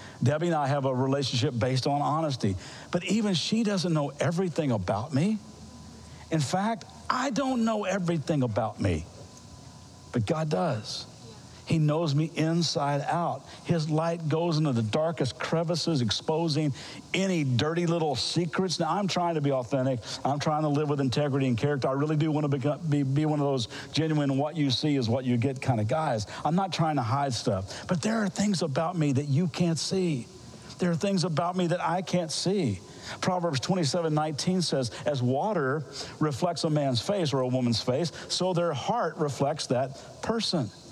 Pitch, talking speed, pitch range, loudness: 155 Hz, 180 wpm, 135-170 Hz, -28 LUFS